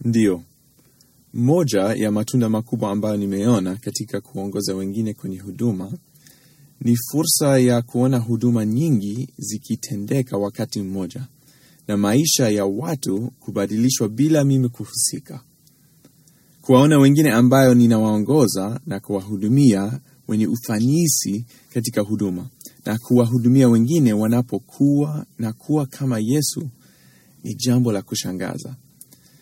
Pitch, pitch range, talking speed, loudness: 120 Hz, 105-140 Hz, 105 wpm, -19 LUFS